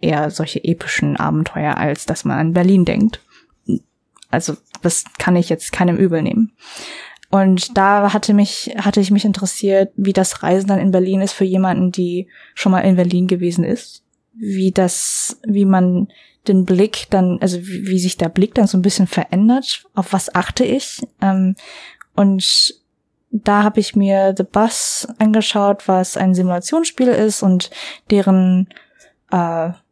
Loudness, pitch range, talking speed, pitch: -16 LUFS, 185-210 Hz, 160 wpm, 195 Hz